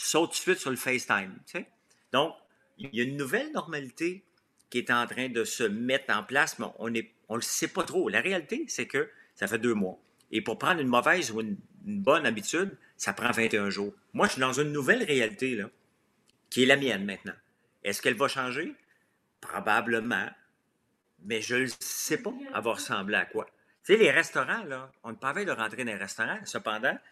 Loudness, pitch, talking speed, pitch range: -29 LUFS, 130 Hz, 210 wpm, 115-170 Hz